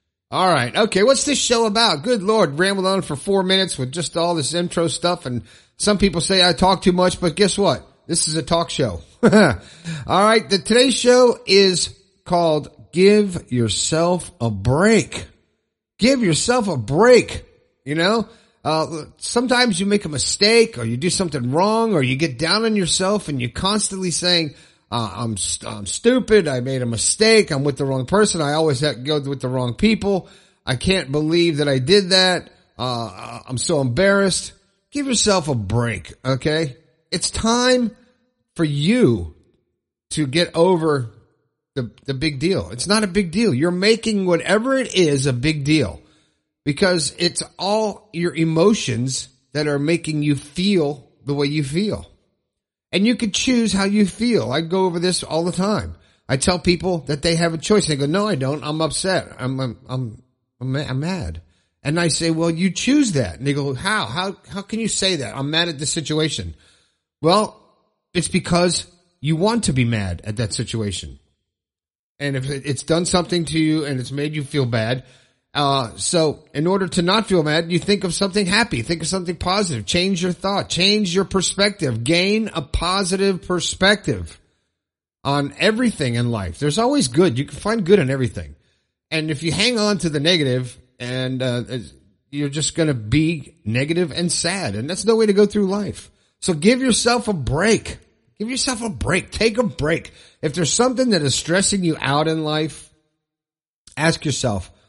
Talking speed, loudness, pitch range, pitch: 185 wpm, -19 LUFS, 135-195 Hz, 165 Hz